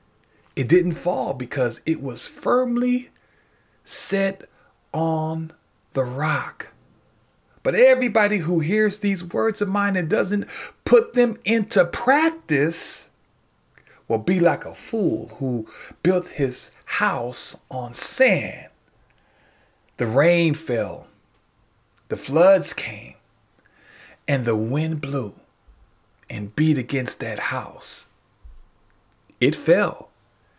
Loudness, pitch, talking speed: -21 LUFS, 160 Hz, 105 wpm